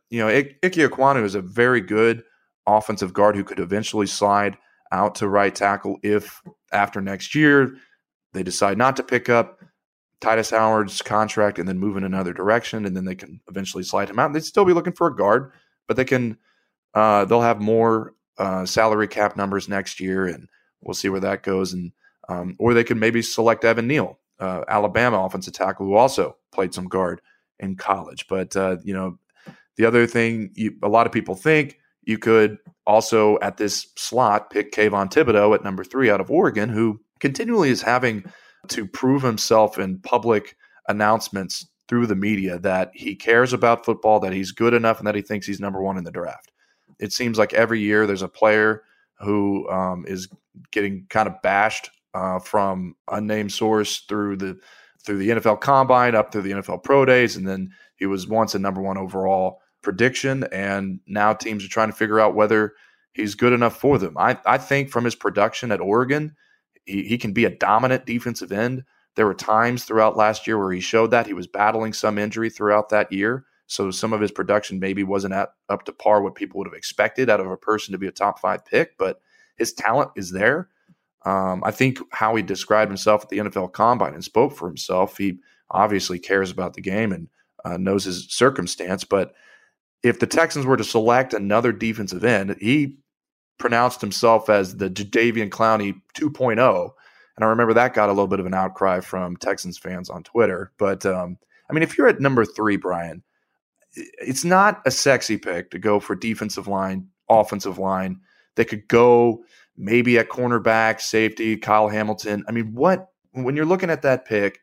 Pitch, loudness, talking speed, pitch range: 105 Hz, -21 LUFS, 195 wpm, 95-115 Hz